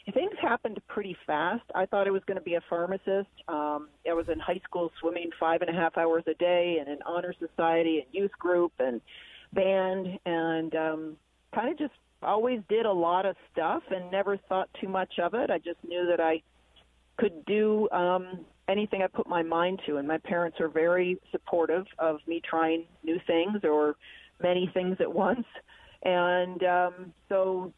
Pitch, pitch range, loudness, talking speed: 175 Hz, 165-190 Hz, -29 LUFS, 190 wpm